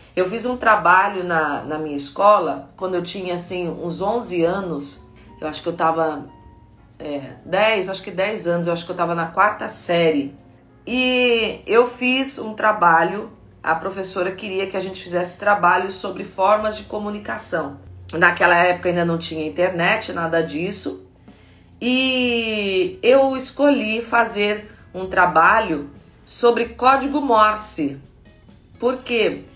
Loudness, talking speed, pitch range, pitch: -19 LUFS, 140 wpm, 165-215 Hz, 185 Hz